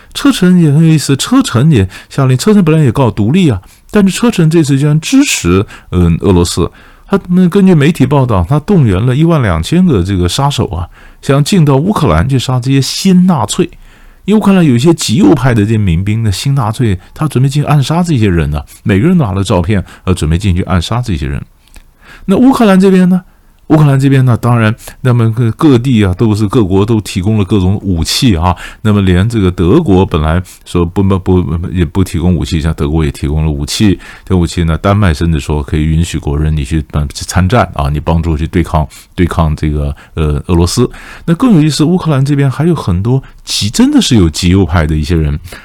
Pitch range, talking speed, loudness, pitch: 85-145 Hz, 315 characters per minute, -10 LUFS, 105 Hz